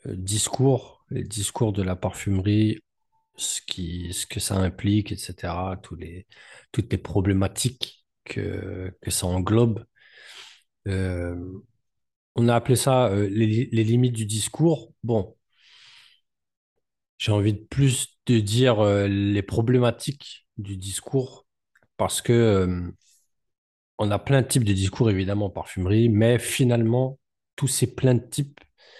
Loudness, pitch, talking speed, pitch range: -24 LUFS, 110 Hz, 135 wpm, 95-125 Hz